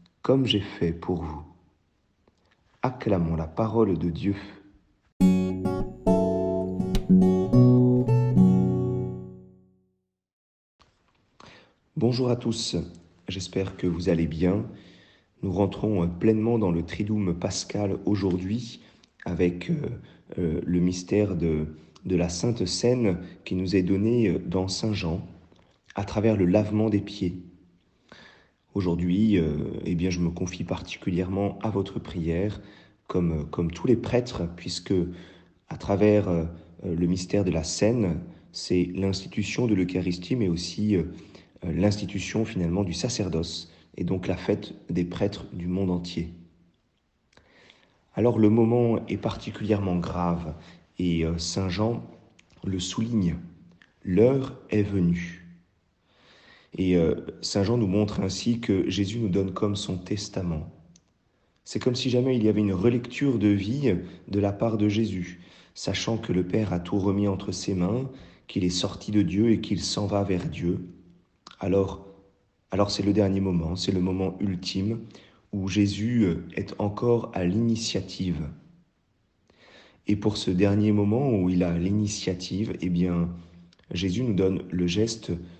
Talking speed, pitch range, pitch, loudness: 130 wpm, 90-105 Hz, 95 Hz, -26 LUFS